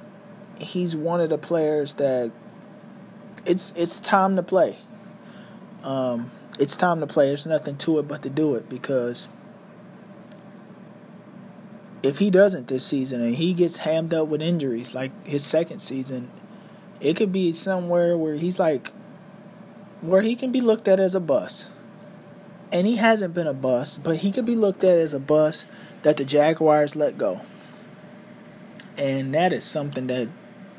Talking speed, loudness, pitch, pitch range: 160 wpm, -23 LUFS, 190 Hz, 150-200 Hz